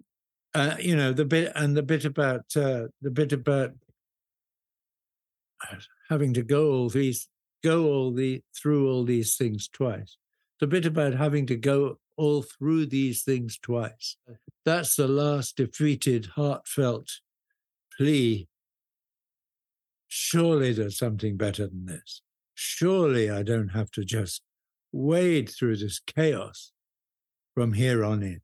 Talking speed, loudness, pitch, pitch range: 135 wpm, -26 LUFS, 135 Hz, 115-150 Hz